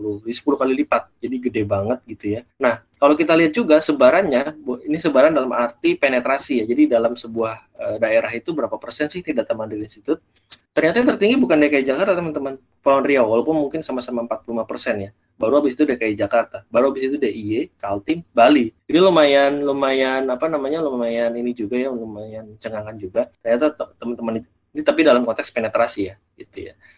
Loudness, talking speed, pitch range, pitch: -19 LUFS, 175 wpm, 115-155 Hz, 130 Hz